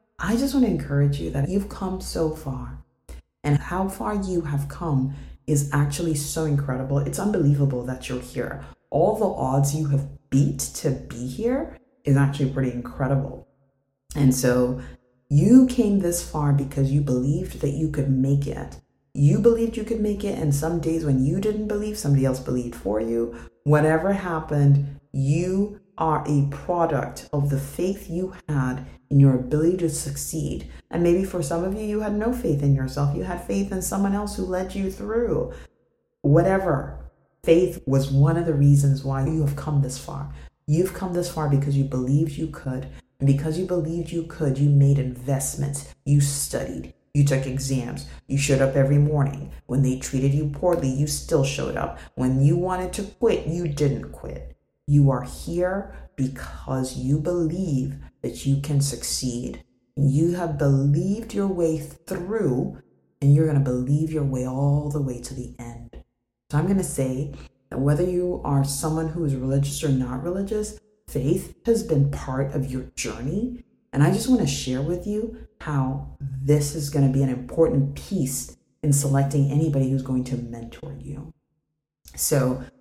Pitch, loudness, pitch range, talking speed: 145 Hz, -23 LUFS, 135-170 Hz, 180 wpm